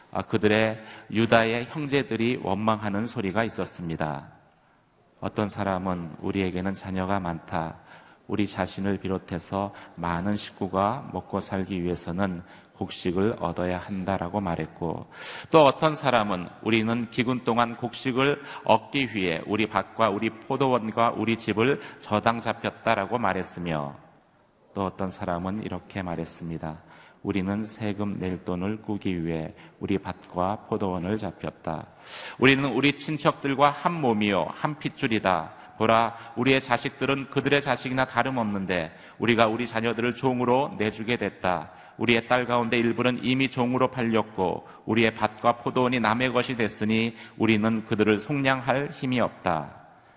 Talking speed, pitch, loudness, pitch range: 305 characters per minute, 110 Hz, -26 LUFS, 95-120 Hz